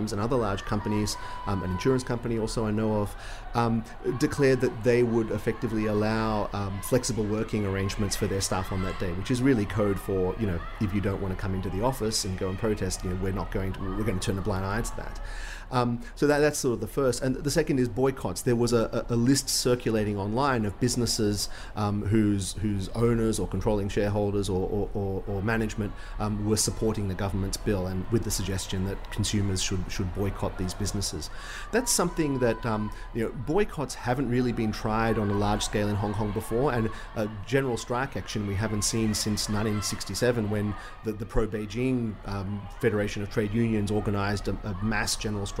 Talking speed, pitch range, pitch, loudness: 210 wpm, 100-115 Hz, 105 Hz, -28 LUFS